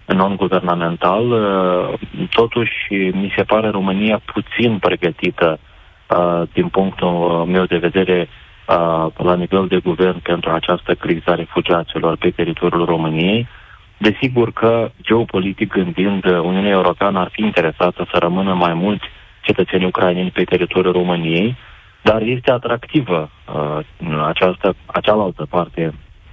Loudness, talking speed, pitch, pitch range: -17 LUFS, 115 wpm, 90 Hz, 85-100 Hz